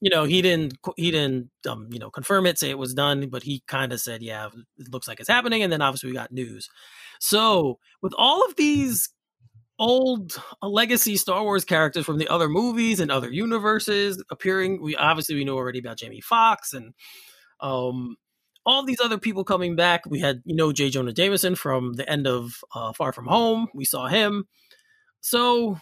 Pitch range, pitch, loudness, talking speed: 130-210 Hz, 160 Hz, -23 LUFS, 200 wpm